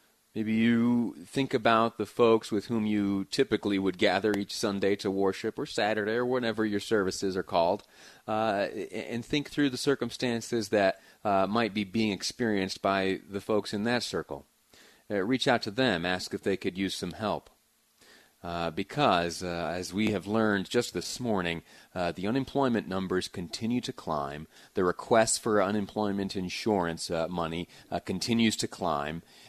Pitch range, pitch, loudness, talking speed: 95-115 Hz, 105 Hz, -29 LUFS, 165 wpm